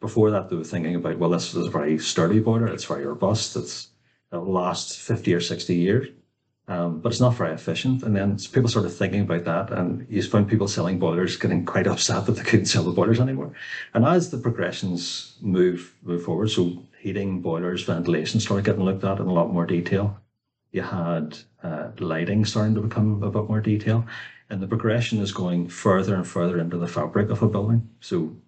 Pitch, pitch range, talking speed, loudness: 100 Hz, 90-110 Hz, 205 wpm, -24 LUFS